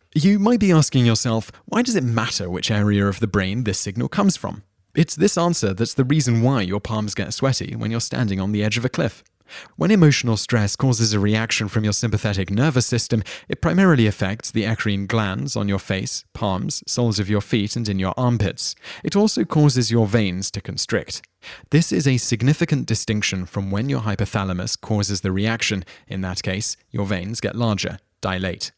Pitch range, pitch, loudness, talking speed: 100-130 Hz, 110 Hz, -20 LUFS, 195 wpm